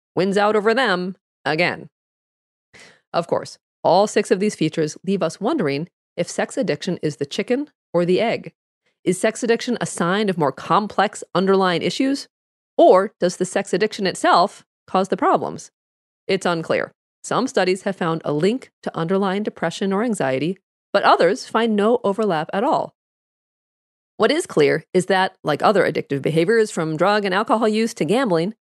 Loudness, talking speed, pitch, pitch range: -20 LUFS, 165 wpm, 195 Hz, 175-215 Hz